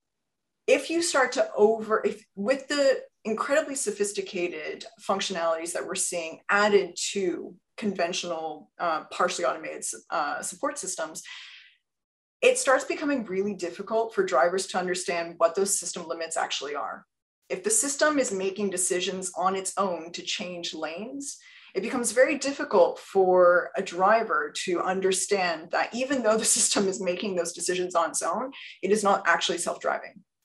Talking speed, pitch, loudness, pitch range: 150 wpm, 200 Hz, -26 LUFS, 180-260 Hz